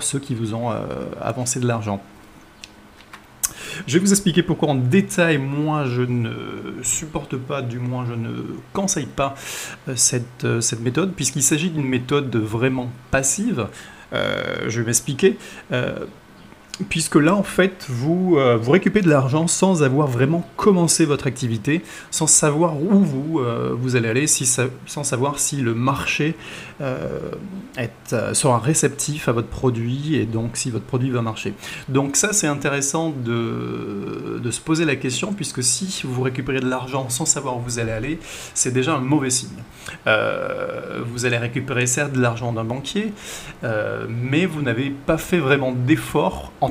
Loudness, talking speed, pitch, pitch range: -21 LUFS, 170 wpm, 140 Hz, 125-160 Hz